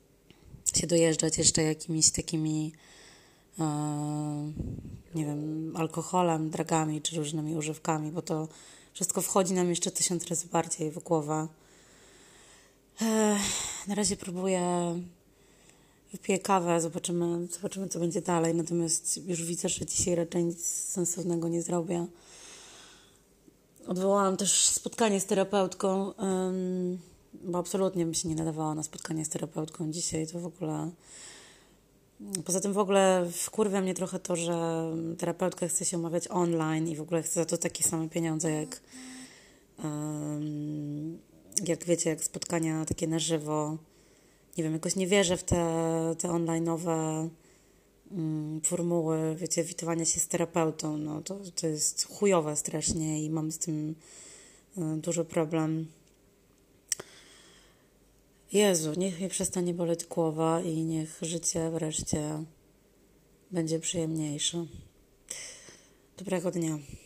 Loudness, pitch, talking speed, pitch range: -30 LUFS, 165 Hz, 125 wpm, 160-180 Hz